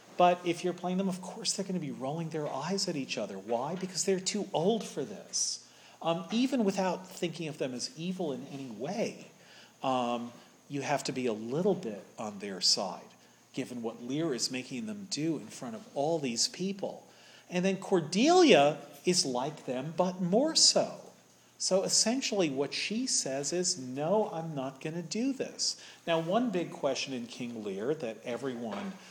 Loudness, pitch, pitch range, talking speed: -31 LUFS, 175 Hz, 140-195 Hz, 185 wpm